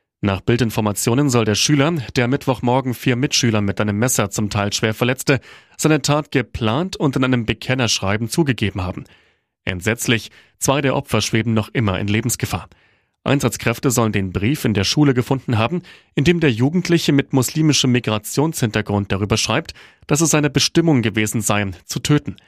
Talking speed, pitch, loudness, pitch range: 160 wpm, 120 Hz, -18 LUFS, 105-140 Hz